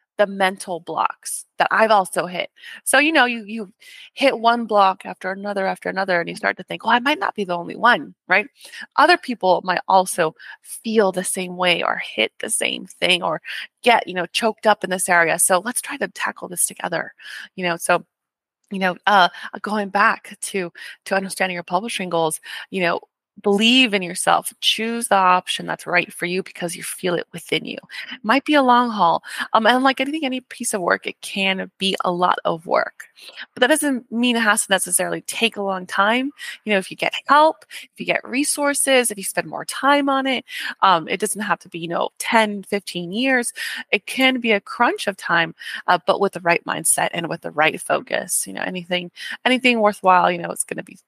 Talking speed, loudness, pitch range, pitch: 215 wpm, -19 LUFS, 180-240 Hz, 200 Hz